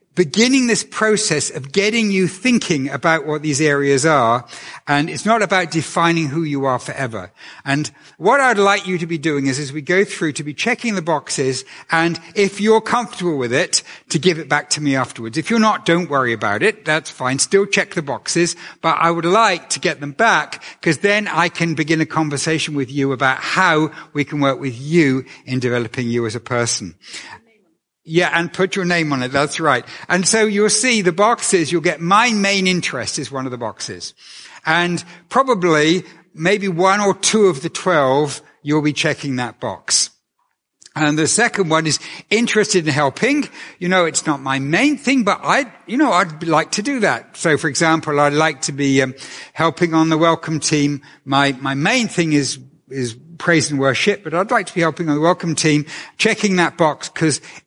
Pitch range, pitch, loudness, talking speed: 145-190 Hz, 165 Hz, -17 LUFS, 200 wpm